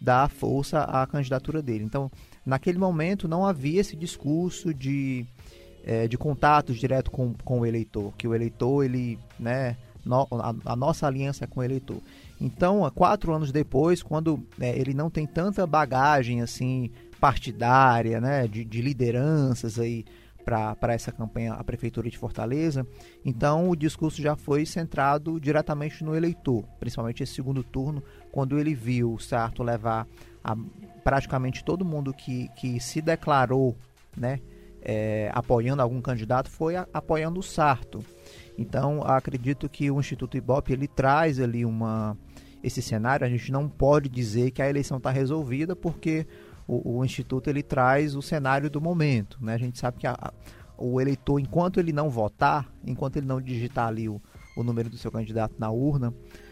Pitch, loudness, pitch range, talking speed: 130 Hz, -27 LUFS, 120-150 Hz, 165 wpm